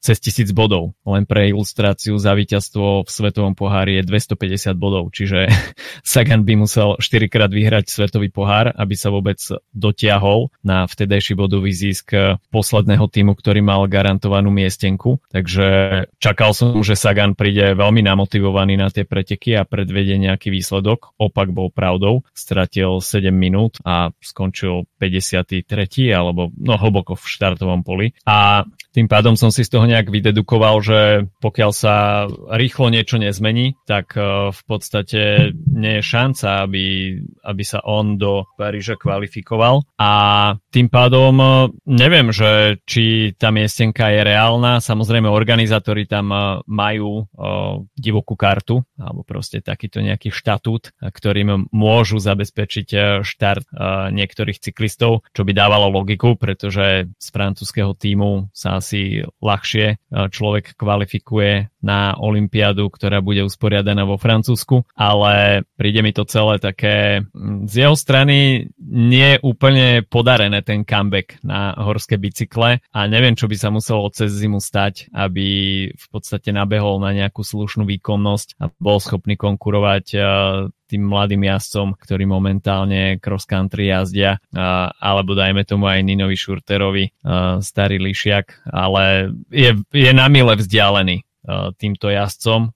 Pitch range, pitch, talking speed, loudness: 100-110 Hz, 105 Hz, 130 wpm, -16 LUFS